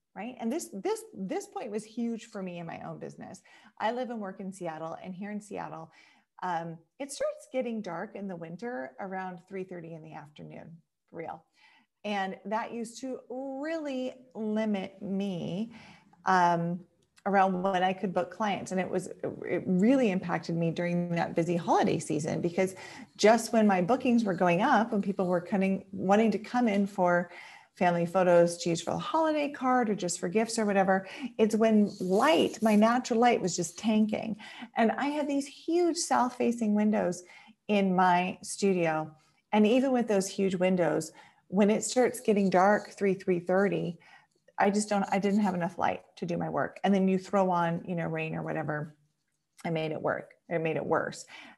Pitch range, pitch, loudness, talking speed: 175-225 Hz, 195 Hz, -29 LUFS, 185 wpm